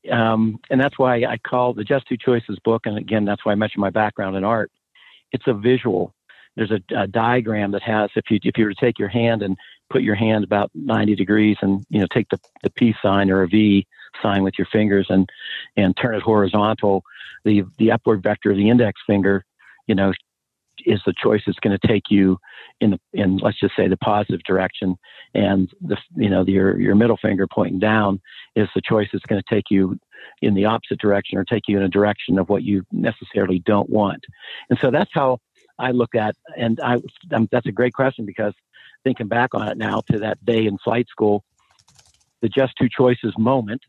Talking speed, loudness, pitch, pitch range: 215 wpm, -20 LUFS, 105 Hz, 100-115 Hz